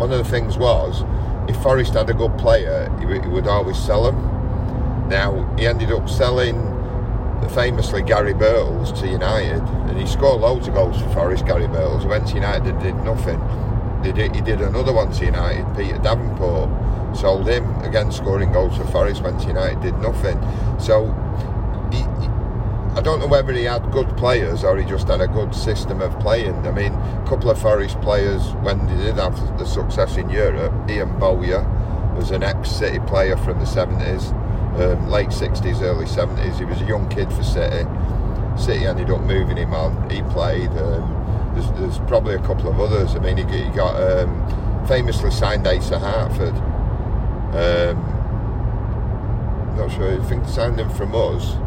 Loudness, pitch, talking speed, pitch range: -20 LUFS, 105 Hz, 180 wpm, 100-115 Hz